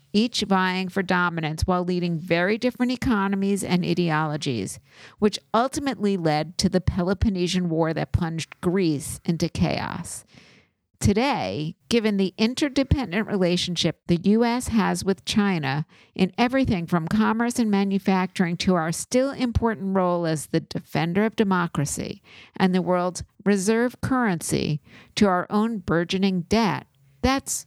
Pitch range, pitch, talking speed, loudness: 170-220 Hz, 185 Hz, 130 wpm, -24 LUFS